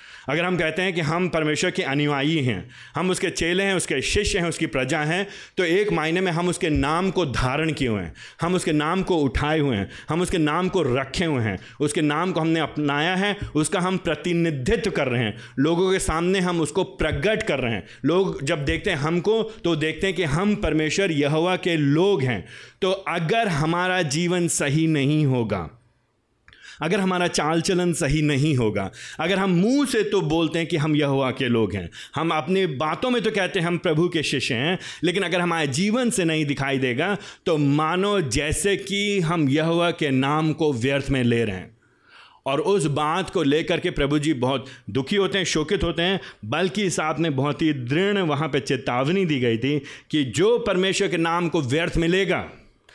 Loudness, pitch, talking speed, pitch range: -22 LUFS, 165 Hz, 205 wpm, 145-185 Hz